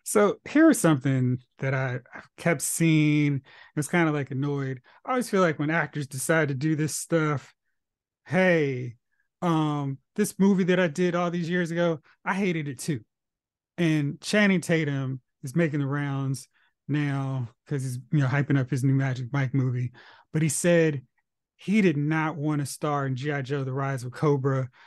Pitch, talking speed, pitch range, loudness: 145 Hz, 180 wpm, 135-170 Hz, -26 LUFS